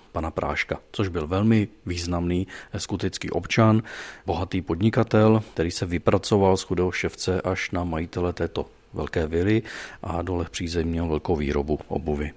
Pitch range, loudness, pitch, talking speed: 85-105 Hz, -25 LUFS, 90 Hz, 140 wpm